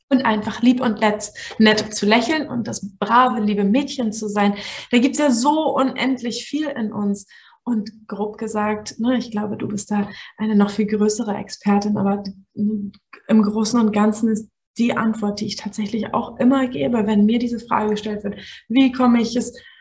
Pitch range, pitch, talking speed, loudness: 210-245 Hz, 220 Hz, 185 wpm, -20 LUFS